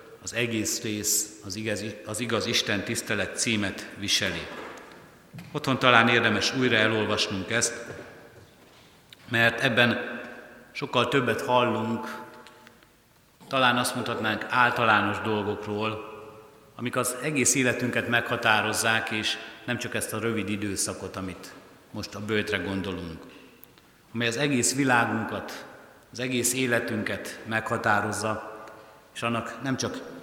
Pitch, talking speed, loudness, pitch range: 115 Hz, 110 wpm, -26 LUFS, 105-120 Hz